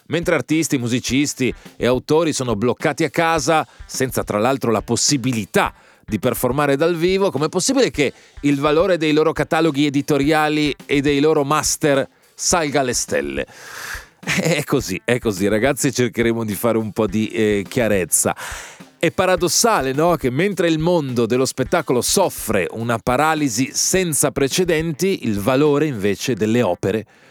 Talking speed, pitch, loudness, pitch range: 145 wpm, 140 Hz, -18 LUFS, 120-160 Hz